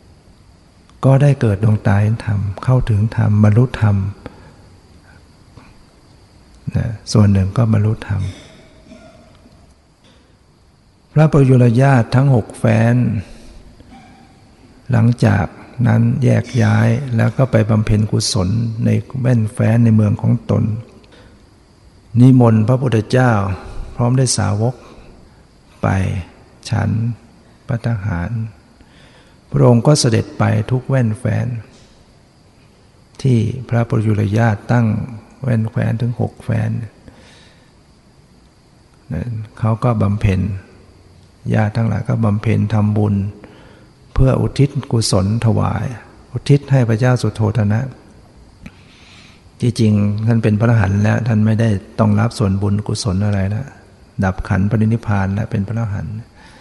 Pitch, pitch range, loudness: 110 Hz, 100-120 Hz, -16 LUFS